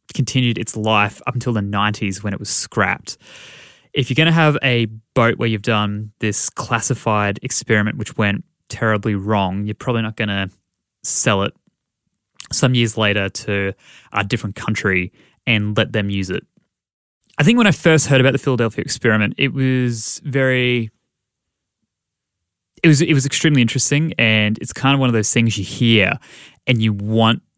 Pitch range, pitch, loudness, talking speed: 105-130 Hz, 115 Hz, -17 LUFS, 170 wpm